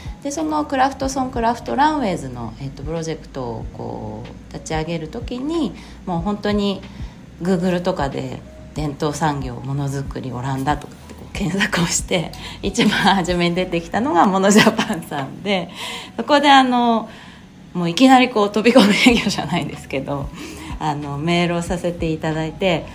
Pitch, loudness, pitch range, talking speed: 180 Hz, -19 LUFS, 155-220 Hz, 360 characters per minute